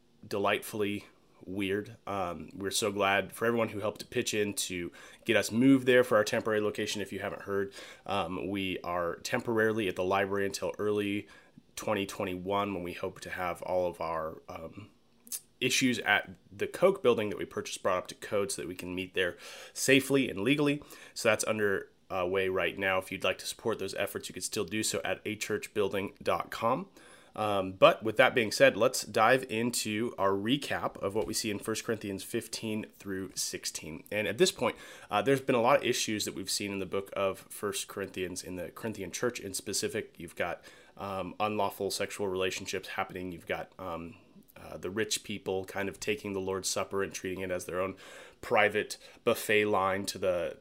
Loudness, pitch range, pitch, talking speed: -31 LUFS, 95-110 Hz, 100 Hz, 195 wpm